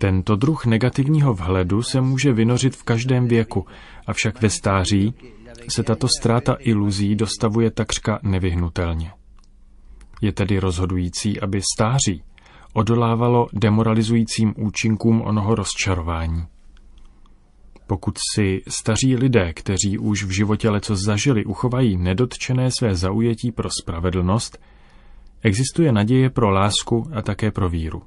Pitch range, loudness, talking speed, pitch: 95-115 Hz, -20 LUFS, 115 wpm, 105 Hz